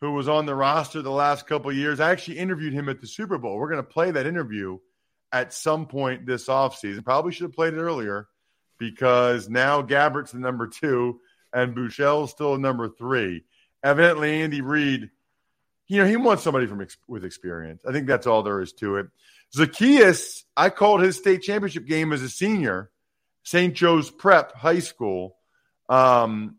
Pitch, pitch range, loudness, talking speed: 140 Hz, 120-160 Hz, -22 LUFS, 185 wpm